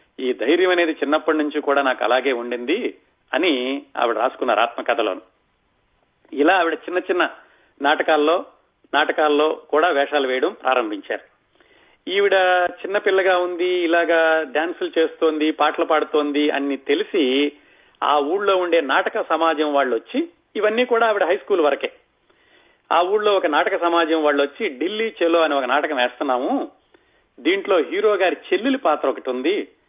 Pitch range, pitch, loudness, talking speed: 150-205 Hz, 165 Hz, -20 LUFS, 135 wpm